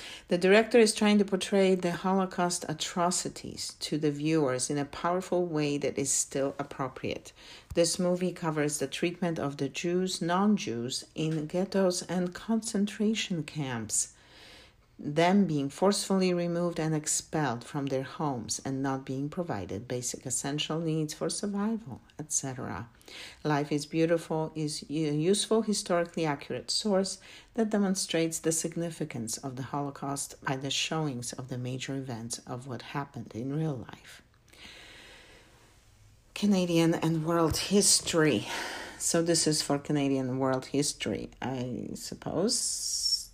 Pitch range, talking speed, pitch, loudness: 135-180 Hz, 135 wpm, 155 Hz, -30 LUFS